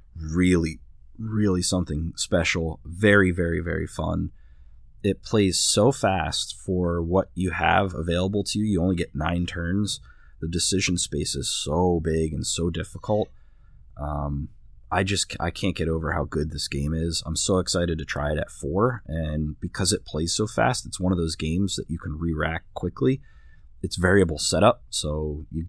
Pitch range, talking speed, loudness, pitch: 80-95 Hz, 175 wpm, -25 LUFS, 85 Hz